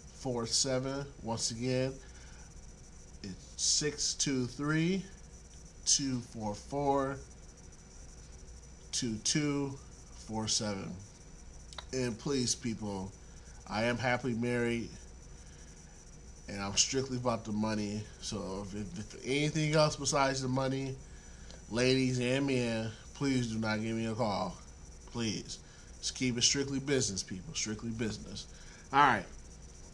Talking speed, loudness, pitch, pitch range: 125 wpm, -33 LUFS, 115 Hz, 95-130 Hz